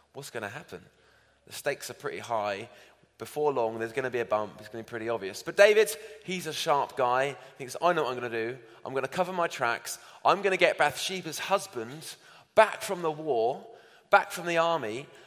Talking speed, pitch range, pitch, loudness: 230 wpm, 115-175 Hz, 140 Hz, -28 LUFS